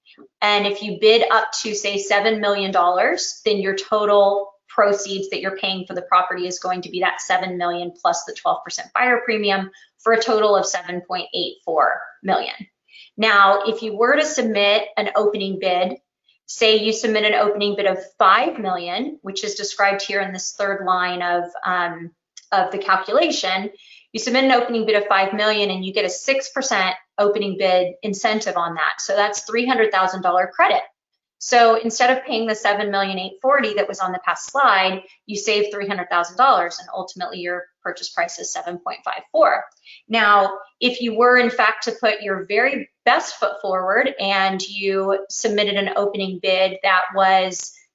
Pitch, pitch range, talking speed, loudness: 200 Hz, 190-220 Hz, 185 wpm, -19 LUFS